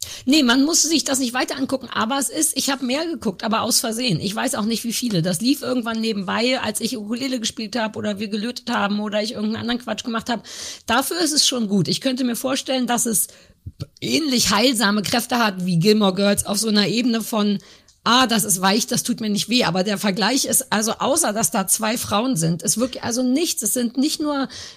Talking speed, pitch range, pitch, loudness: 230 wpm, 210-260 Hz, 235 Hz, -20 LUFS